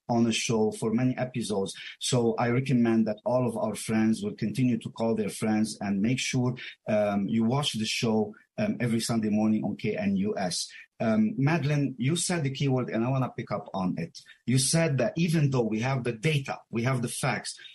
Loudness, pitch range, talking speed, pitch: -28 LUFS, 110-140 Hz, 205 wpm, 120 Hz